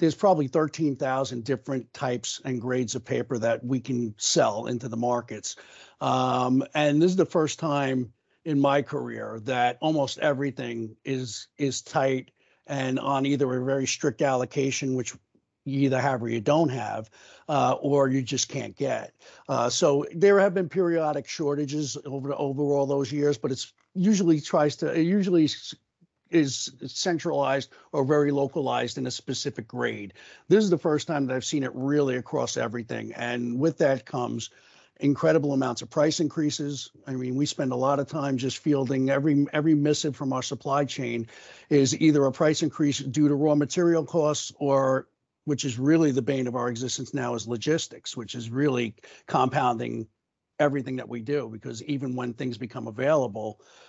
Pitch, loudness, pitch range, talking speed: 140 Hz, -26 LUFS, 125-150 Hz, 175 wpm